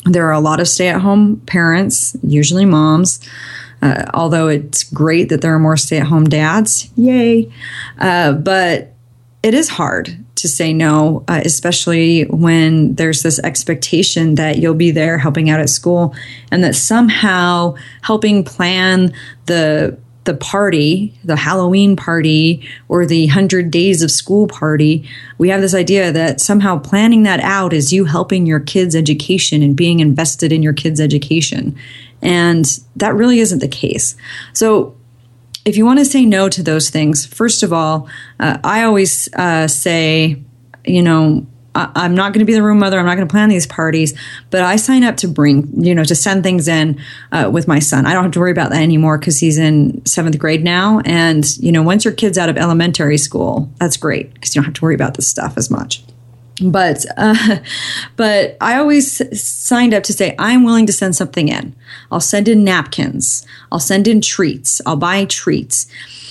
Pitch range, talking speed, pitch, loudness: 150-190 Hz, 185 wpm, 165 Hz, -12 LUFS